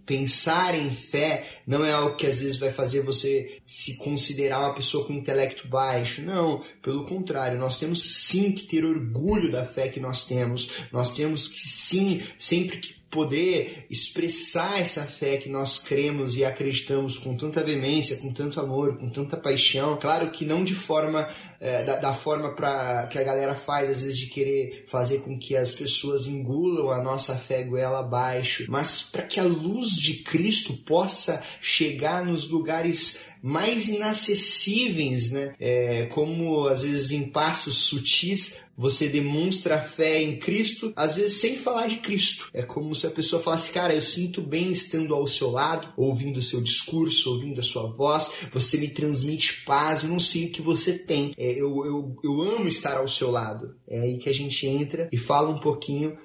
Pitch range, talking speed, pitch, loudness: 135-165 Hz, 180 wpm, 145 Hz, -25 LUFS